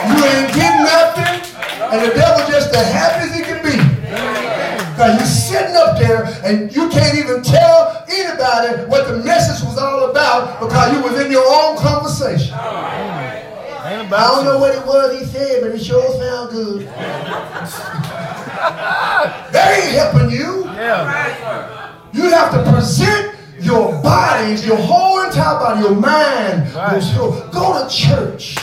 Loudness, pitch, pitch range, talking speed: -14 LUFS, 270 Hz, 225-325 Hz, 150 wpm